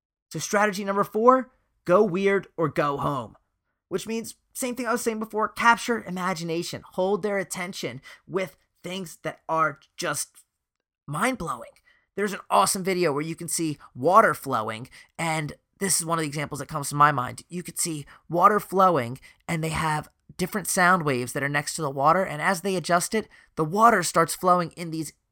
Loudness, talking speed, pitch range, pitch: -24 LUFS, 185 wpm, 155-195 Hz, 175 Hz